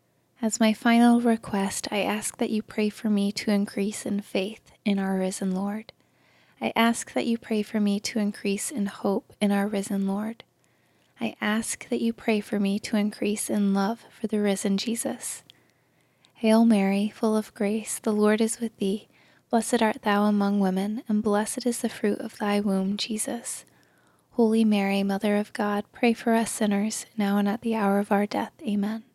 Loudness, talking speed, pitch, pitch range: -26 LUFS, 185 wpm, 210 Hz, 200-225 Hz